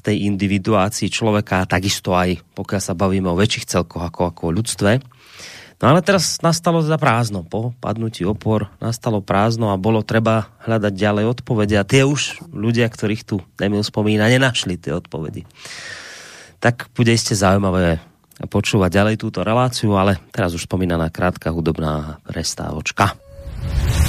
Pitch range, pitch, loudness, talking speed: 95-115 Hz, 105 Hz, -19 LUFS, 145 wpm